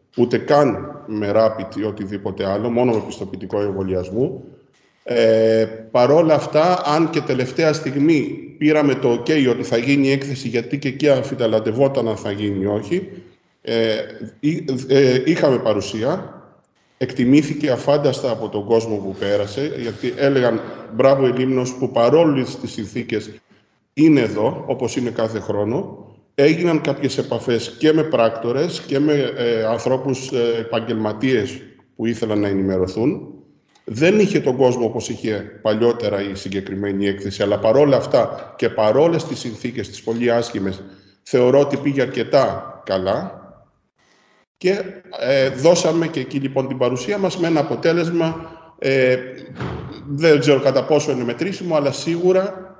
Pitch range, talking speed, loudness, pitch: 110-145 Hz, 140 wpm, -19 LUFS, 125 Hz